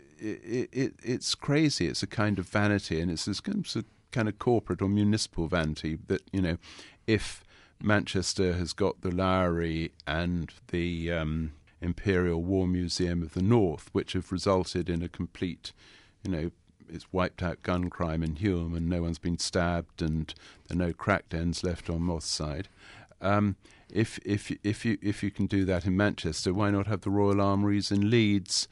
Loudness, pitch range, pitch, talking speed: -30 LUFS, 85-100 Hz, 95 Hz, 180 wpm